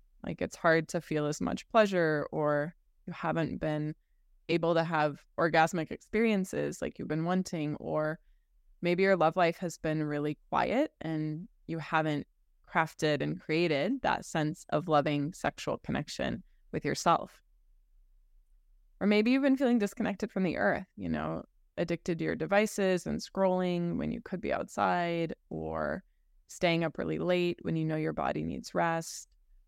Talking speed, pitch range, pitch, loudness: 160 wpm, 150-185 Hz, 165 Hz, -31 LUFS